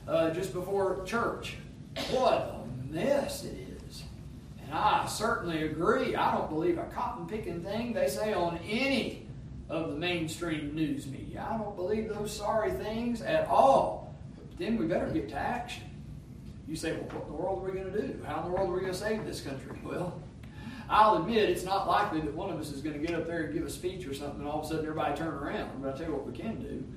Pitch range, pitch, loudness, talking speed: 155-210 Hz, 180 Hz, -32 LUFS, 235 wpm